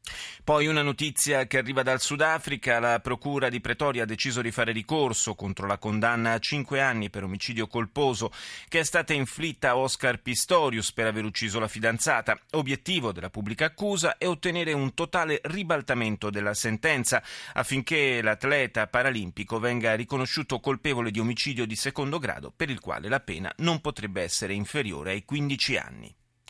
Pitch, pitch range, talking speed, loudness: 125 Hz, 110-145 Hz, 160 wpm, -27 LUFS